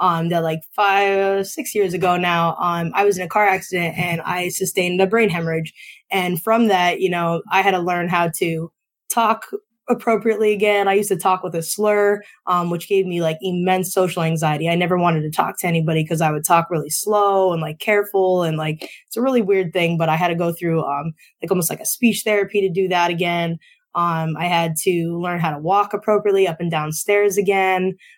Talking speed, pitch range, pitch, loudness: 220 wpm, 170-200 Hz, 180 Hz, -19 LUFS